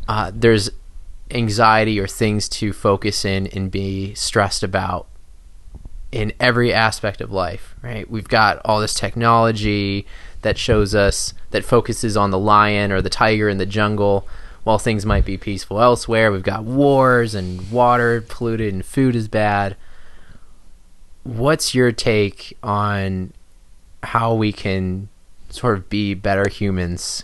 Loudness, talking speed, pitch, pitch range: -18 LUFS, 145 wpm, 105 Hz, 95-115 Hz